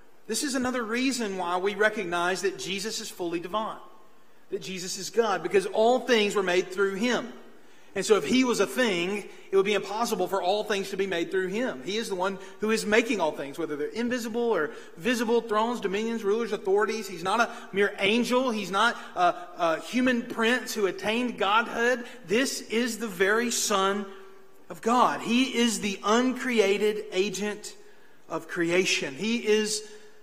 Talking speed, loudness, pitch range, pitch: 180 wpm, -27 LUFS, 195-235 Hz, 210 Hz